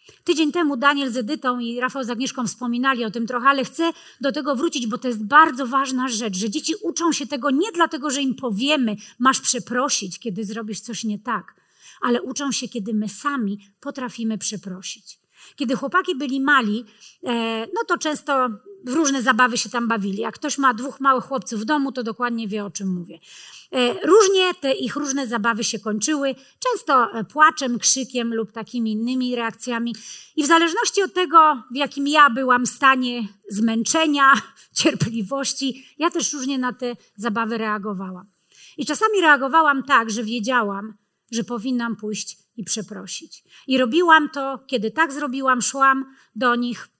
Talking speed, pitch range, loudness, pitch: 165 wpm, 225-285 Hz, -21 LUFS, 250 Hz